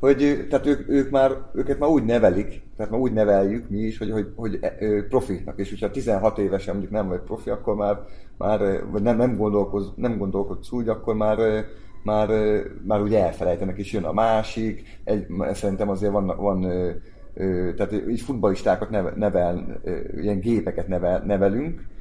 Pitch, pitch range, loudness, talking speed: 105 Hz, 100-110 Hz, -24 LUFS, 175 wpm